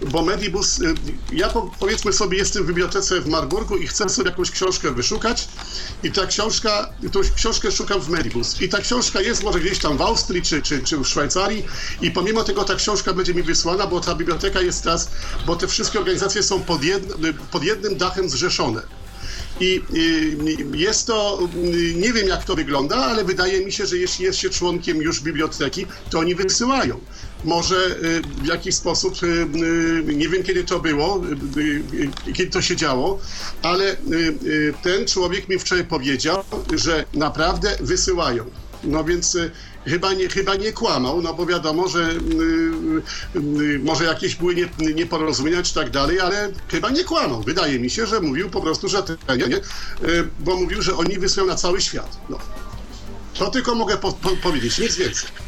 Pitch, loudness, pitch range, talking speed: 185 Hz, -20 LUFS, 165-205 Hz, 165 wpm